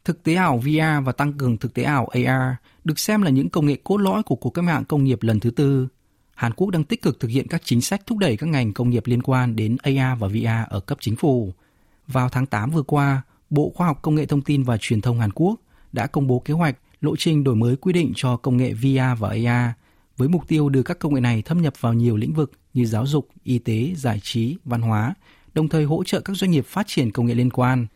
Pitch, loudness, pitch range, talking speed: 130 Hz, -21 LUFS, 120-155 Hz, 265 wpm